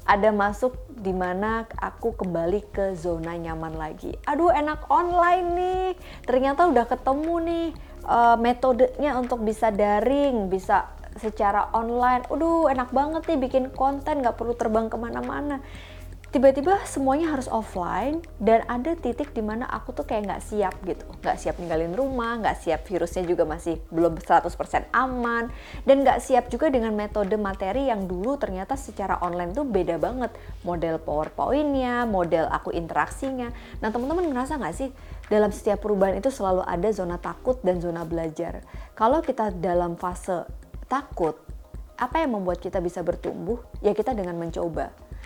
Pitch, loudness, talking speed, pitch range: 225 Hz, -25 LUFS, 150 wpm, 180-265 Hz